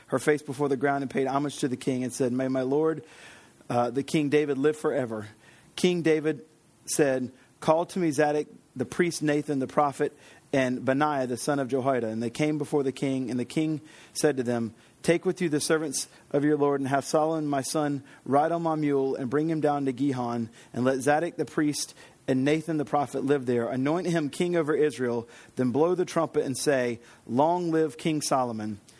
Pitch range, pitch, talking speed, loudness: 130-155 Hz, 145 Hz, 210 wpm, -27 LUFS